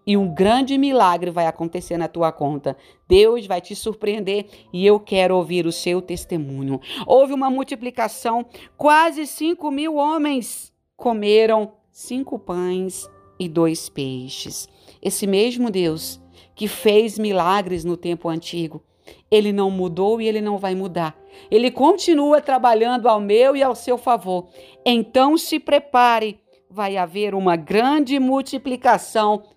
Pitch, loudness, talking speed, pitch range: 210 Hz, -19 LUFS, 135 wpm, 180-255 Hz